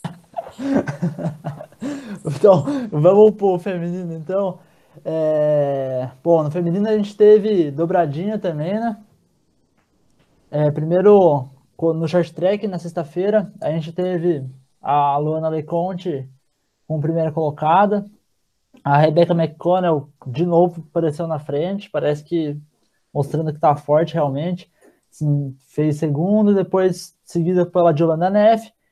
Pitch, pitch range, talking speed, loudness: 170 Hz, 150-190 Hz, 110 wpm, -19 LUFS